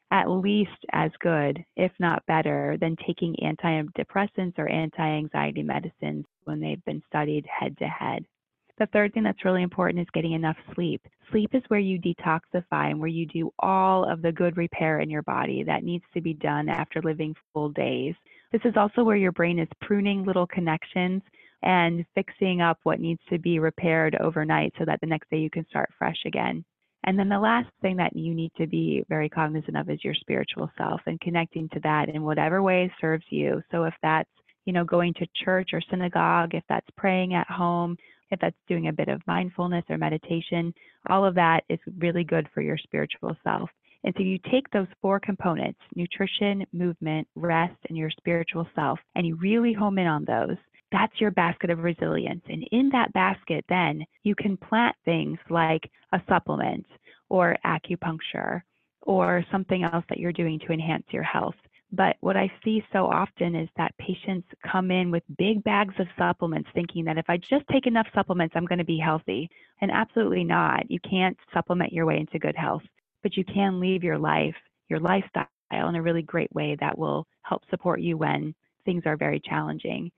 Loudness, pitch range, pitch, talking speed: -26 LUFS, 160-190 Hz, 175 Hz, 195 wpm